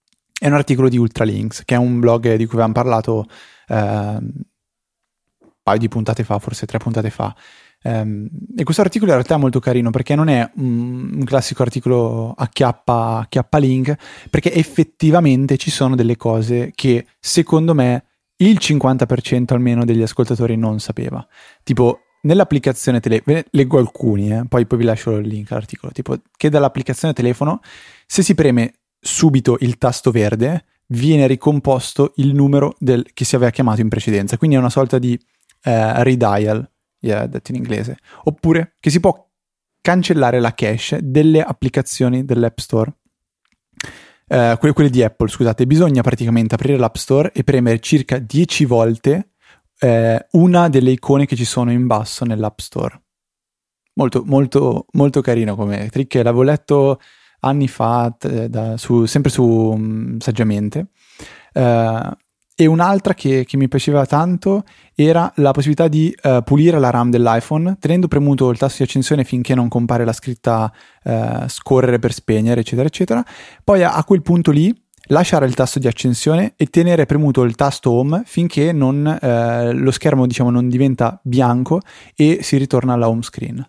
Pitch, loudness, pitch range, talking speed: 130 Hz, -16 LUFS, 115-150 Hz, 160 wpm